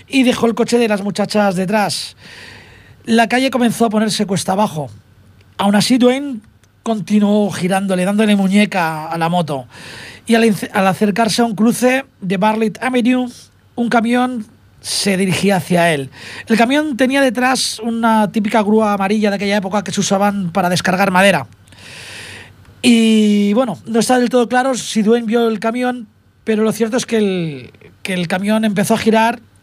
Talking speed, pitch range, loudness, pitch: 165 wpm, 185-230 Hz, -15 LUFS, 210 Hz